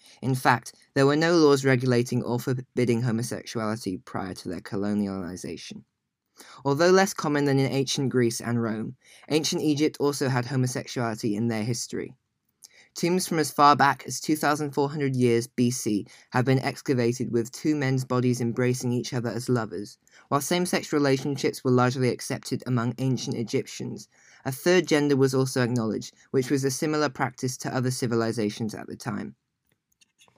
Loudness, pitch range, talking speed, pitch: -25 LUFS, 120-140 Hz, 155 wpm, 130 Hz